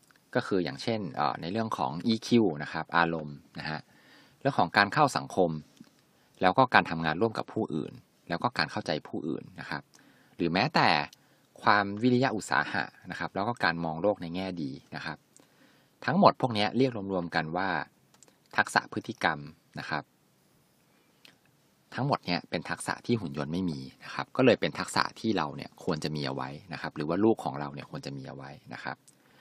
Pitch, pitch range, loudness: 85 Hz, 75-110 Hz, -29 LUFS